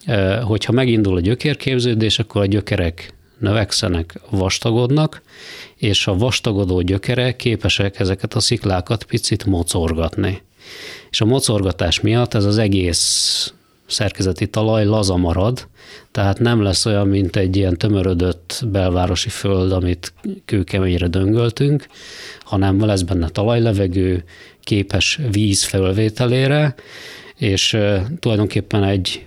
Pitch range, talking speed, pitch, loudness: 95-115 Hz, 110 wpm, 100 Hz, -17 LUFS